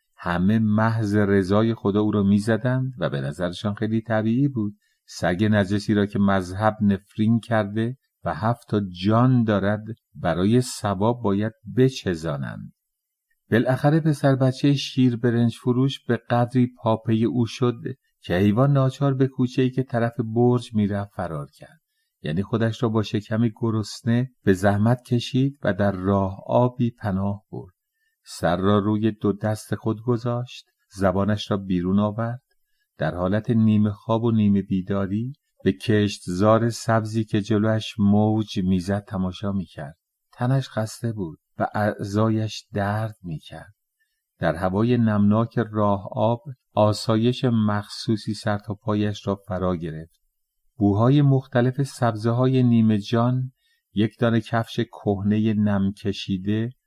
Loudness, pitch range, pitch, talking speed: -23 LUFS, 100-120 Hz, 110 Hz, 135 wpm